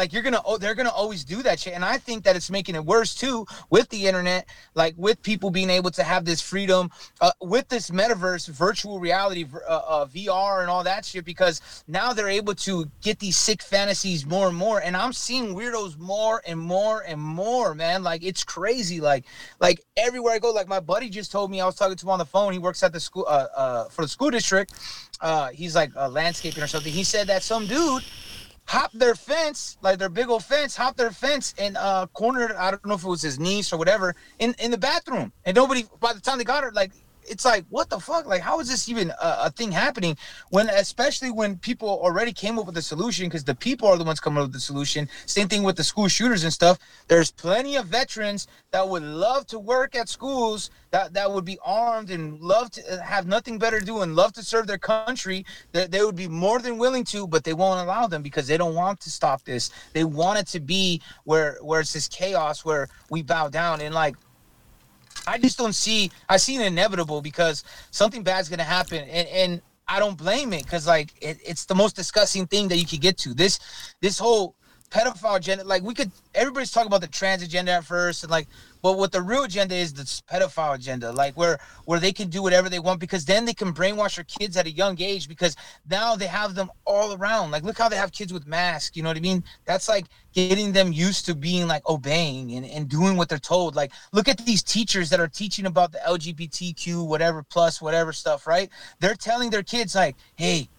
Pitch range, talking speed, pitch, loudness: 170-220 Hz, 235 wpm, 190 Hz, -24 LUFS